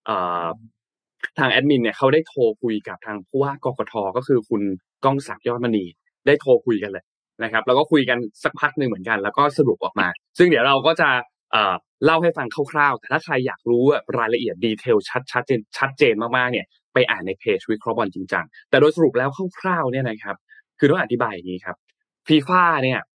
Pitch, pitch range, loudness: 130 Hz, 115-155 Hz, -20 LUFS